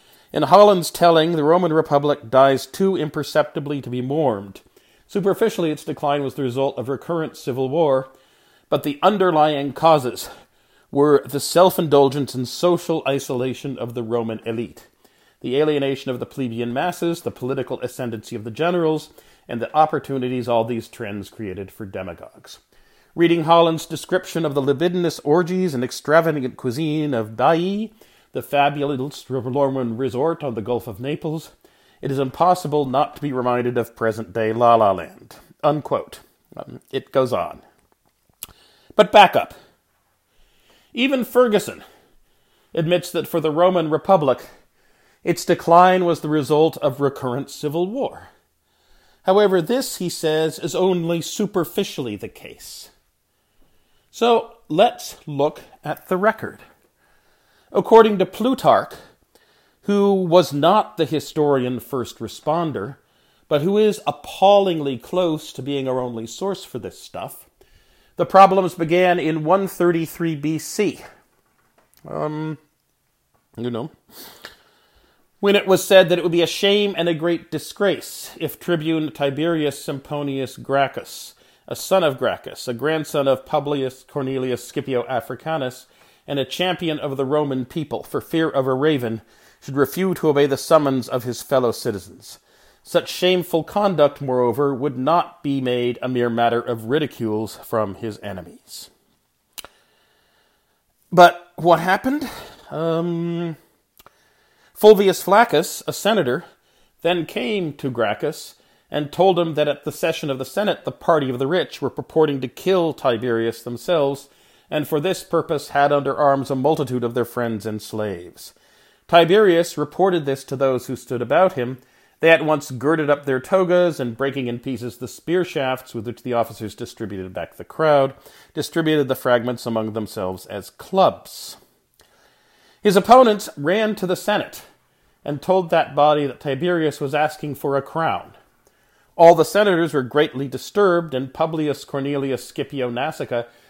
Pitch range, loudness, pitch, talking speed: 130-170 Hz, -20 LUFS, 150 Hz, 145 wpm